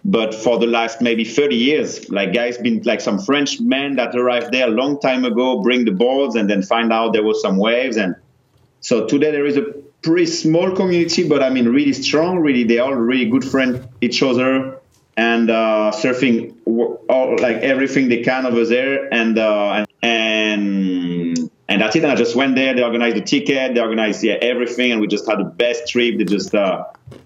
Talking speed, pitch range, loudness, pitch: 205 wpm, 115-135 Hz, -17 LUFS, 120 Hz